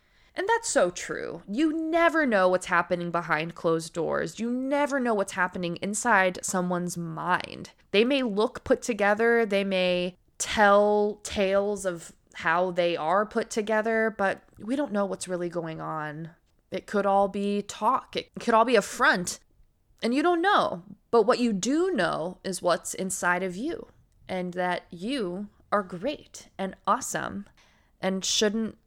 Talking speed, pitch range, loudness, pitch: 160 wpm, 180-225 Hz, -26 LUFS, 200 Hz